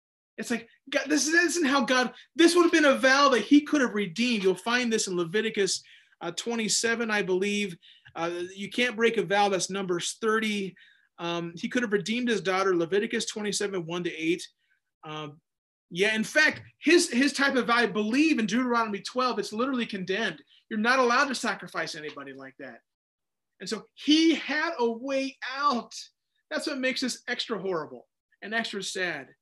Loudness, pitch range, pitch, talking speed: -26 LUFS, 195-270 Hz, 230 Hz, 180 wpm